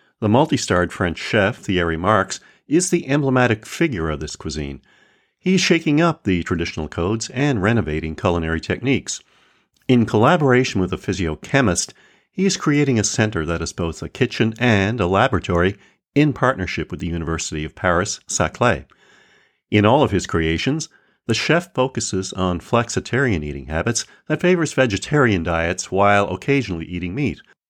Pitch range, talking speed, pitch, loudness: 85-130 Hz, 150 wpm, 105 Hz, -19 LUFS